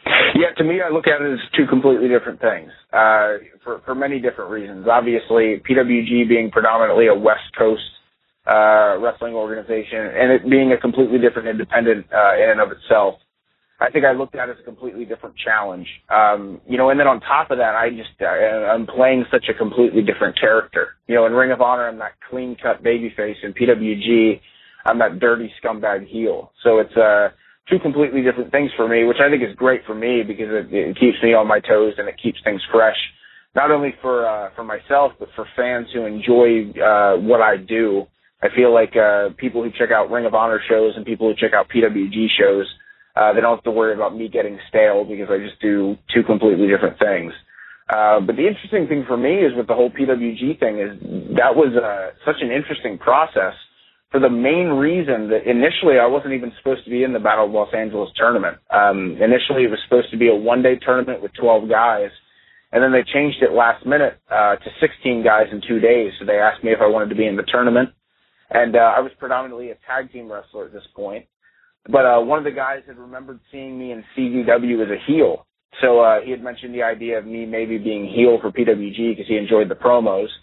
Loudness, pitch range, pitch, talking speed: -17 LUFS, 110-130 Hz, 120 Hz, 225 wpm